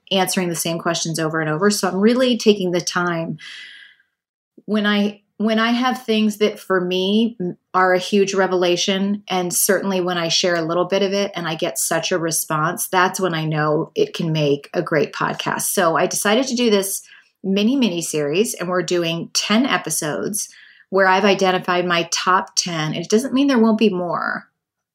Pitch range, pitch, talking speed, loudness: 170-210 Hz, 185 Hz, 190 wpm, -19 LUFS